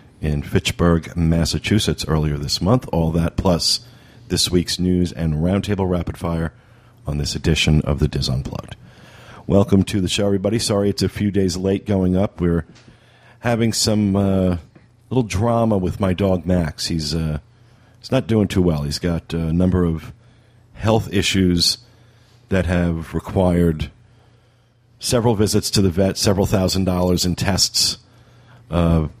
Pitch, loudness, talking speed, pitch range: 95 Hz, -19 LUFS, 150 wpm, 85-115 Hz